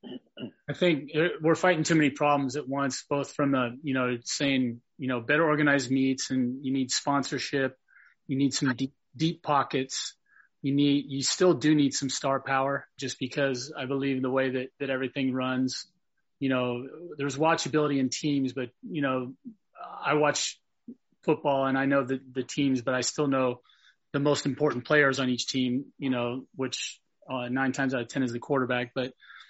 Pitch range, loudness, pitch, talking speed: 130-145 Hz, -28 LUFS, 135 Hz, 185 wpm